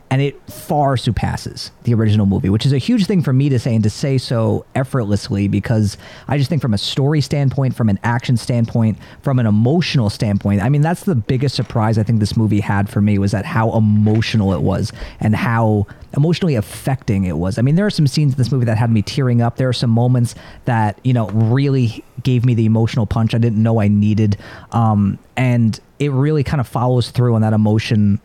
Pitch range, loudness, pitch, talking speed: 105-135 Hz, -17 LUFS, 115 Hz, 225 wpm